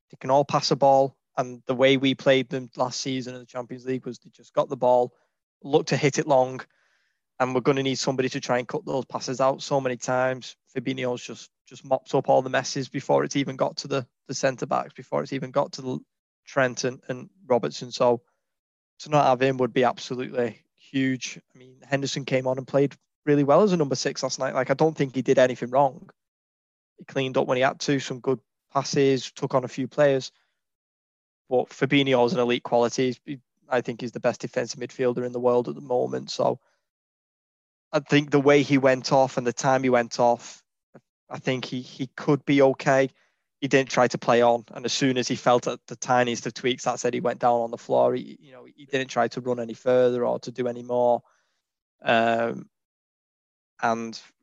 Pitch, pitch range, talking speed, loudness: 130 Hz, 125-140 Hz, 220 wpm, -24 LUFS